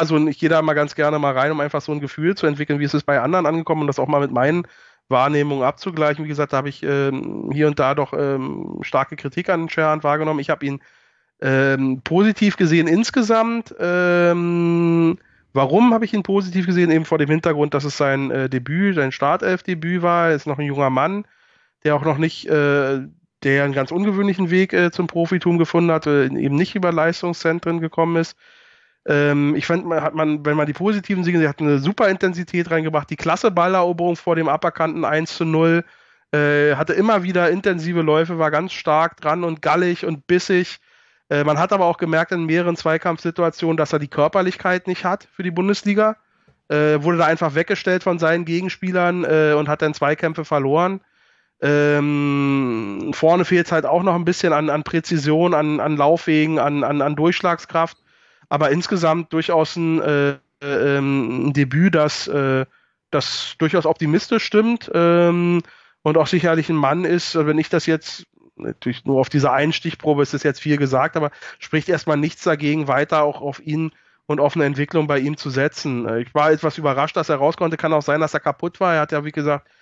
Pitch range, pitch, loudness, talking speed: 145-175 Hz, 160 Hz, -19 LUFS, 195 wpm